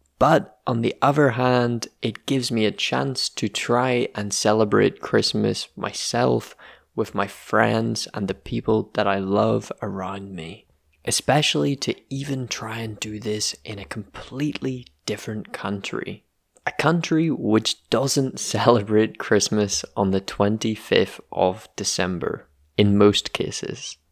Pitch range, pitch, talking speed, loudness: 100-125 Hz, 110 Hz, 130 wpm, -22 LUFS